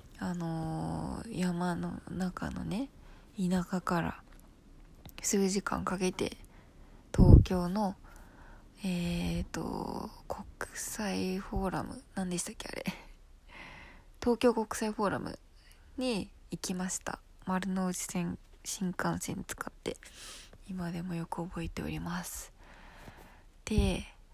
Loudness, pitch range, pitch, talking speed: -34 LUFS, 170-195 Hz, 180 Hz, 190 characters per minute